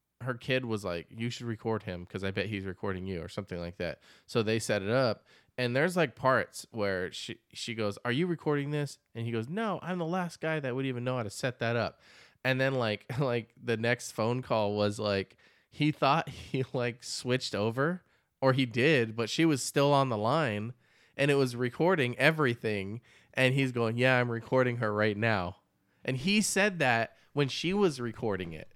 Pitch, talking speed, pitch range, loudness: 125 Hz, 210 wpm, 110-140 Hz, -31 LUFS